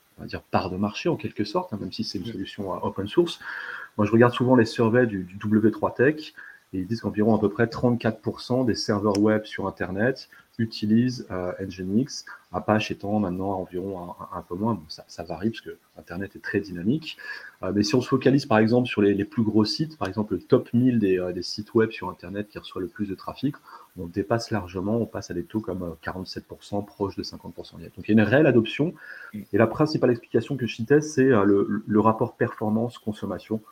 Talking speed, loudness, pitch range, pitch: 230 wpm, -25 LUFS, 95-115 Hz, 105 Hz